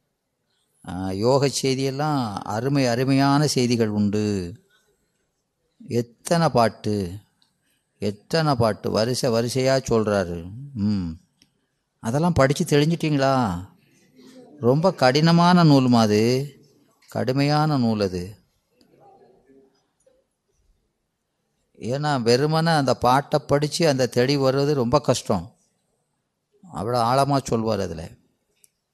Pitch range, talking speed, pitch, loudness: 110-145 Hz, 80 wpm, 130 Hz, -21 LUFS